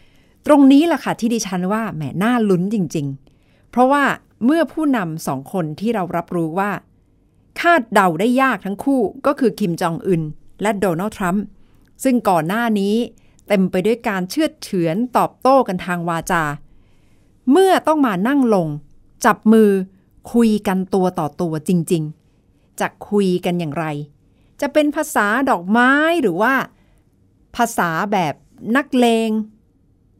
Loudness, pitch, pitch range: -18 LUFS, 205 Hz, 175-245 Hz